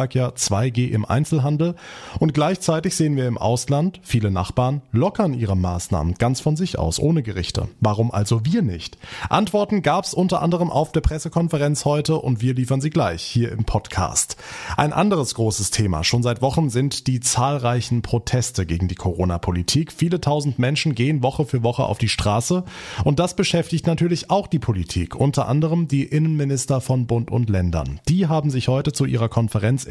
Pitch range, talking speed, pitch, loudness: 115-155 Hz, 180 wpm, 130 Hz, -21 LUFS